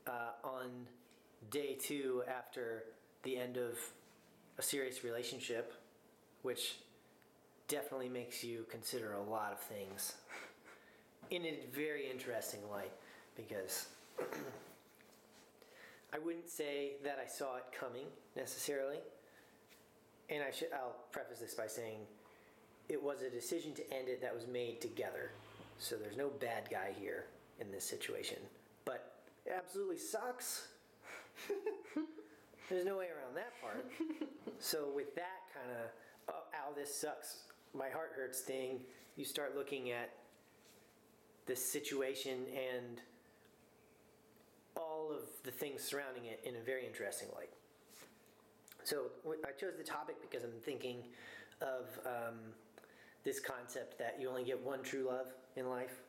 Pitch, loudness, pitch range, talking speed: 135 Hz, -45 LUFS, 125-190 Hz, 130 wpm